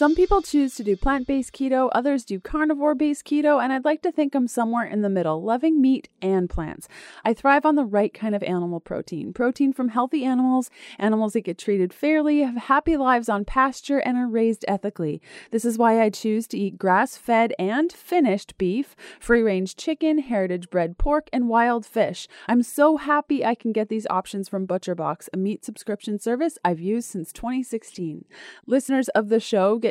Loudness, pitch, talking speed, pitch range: -23 LUFS, 235 Hz, 195 wpm, 205-275 Hz